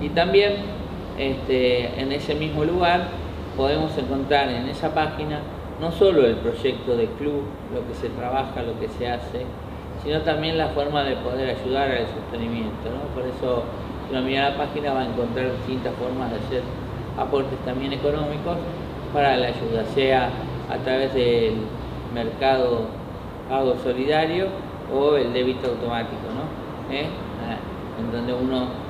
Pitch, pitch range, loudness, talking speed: 130 Hz, 120-145 Hz, -24 LUFS, 150 wpm